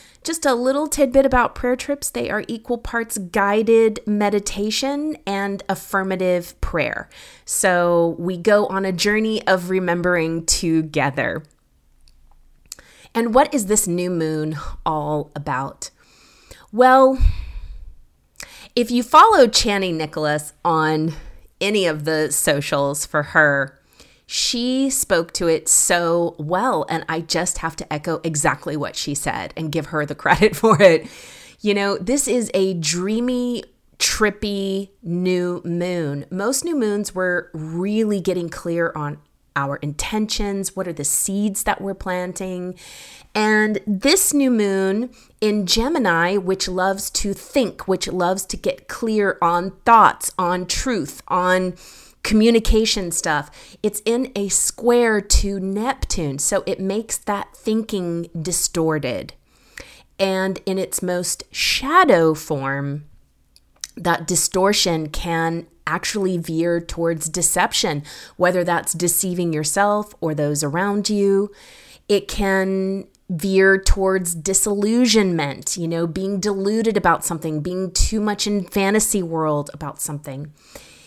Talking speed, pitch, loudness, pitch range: 125 wpm, 185 Hz, -19 LUFS, 165-210 Hz